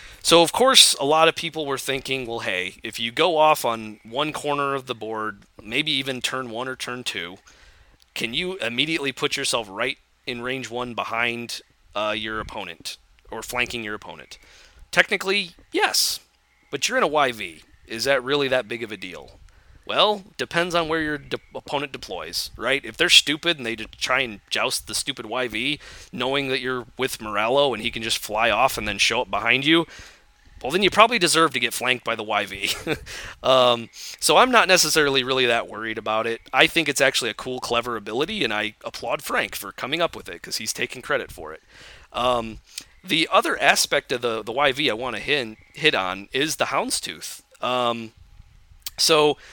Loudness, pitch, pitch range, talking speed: -21 LUFS, 125 Hz, 115-150 Hz, 195 wpm